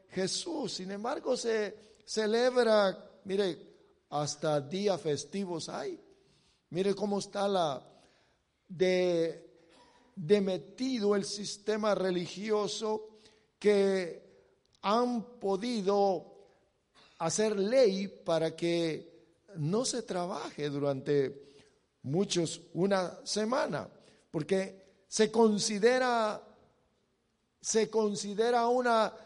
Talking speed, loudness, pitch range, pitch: 80 wpm, -31 LUFS, 175-220 Hz, 200 Hz